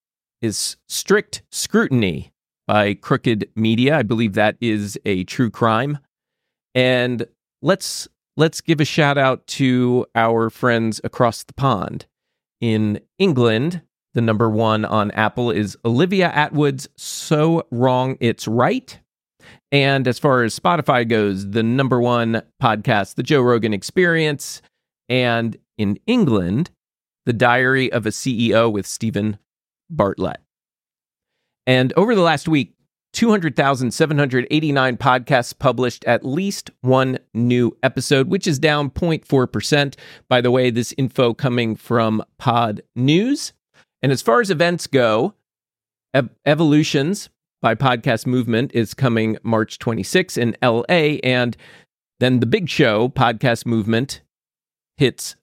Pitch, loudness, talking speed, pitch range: 125 Hz, -18 LUFS, 125 wpm, 115-145 Hz